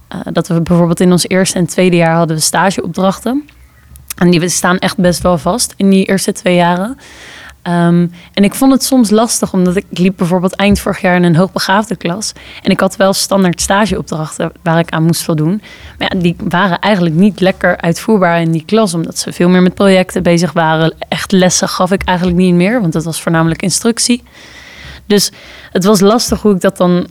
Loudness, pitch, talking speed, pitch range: -11 LUFS, 185 Hz, 210 wpm, 175-200 Hz